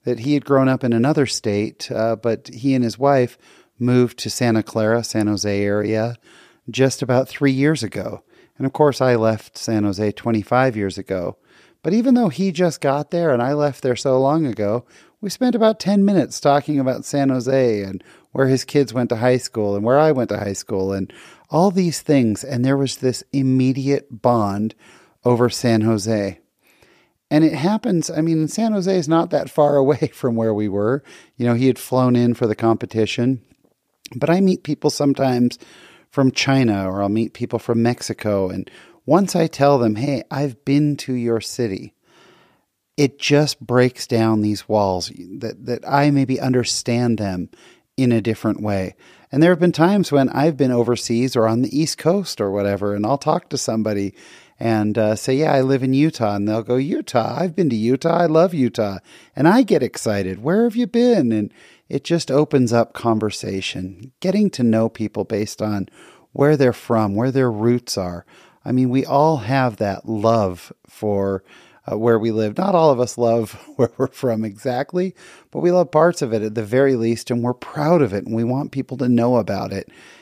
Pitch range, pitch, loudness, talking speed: 110-145 Hz, 125 Hz, -19 LUFS, 195 wpm